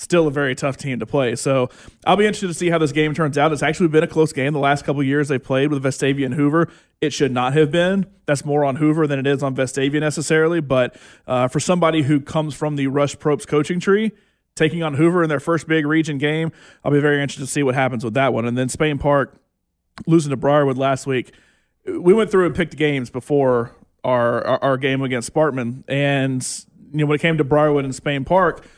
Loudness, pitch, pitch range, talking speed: -19 LUFS, 145 Hz, 135-160 Hz, 240 wpm